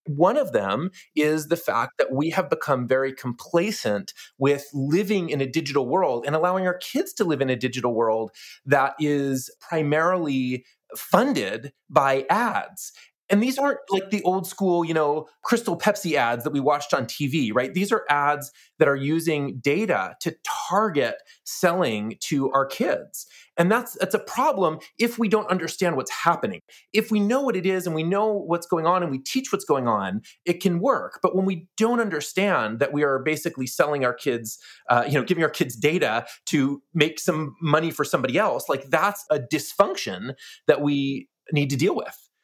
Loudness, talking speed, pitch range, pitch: -24 LUFS, 190 wpm, 140-190 Hz, 155 Hz